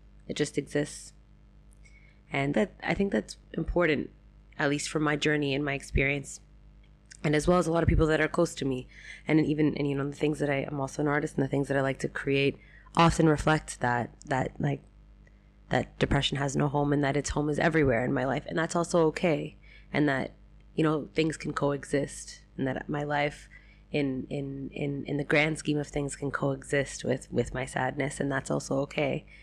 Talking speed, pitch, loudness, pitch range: 210 wpm, 145 Hz, -29 LUFS, 140-155 Hz